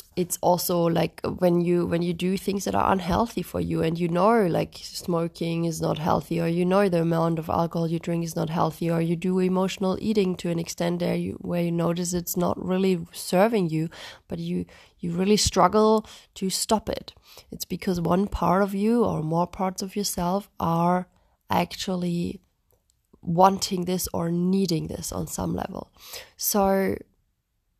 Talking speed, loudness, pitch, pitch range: 175 wpm, -25 LUFS, 175 Hz, 170-190 Hz